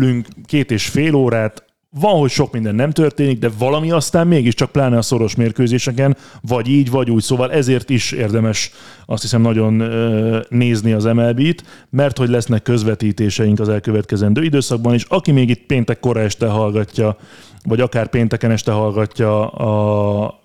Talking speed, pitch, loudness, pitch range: 155 wpm, 120 Hz, -16 LUFS, 110-135 Hz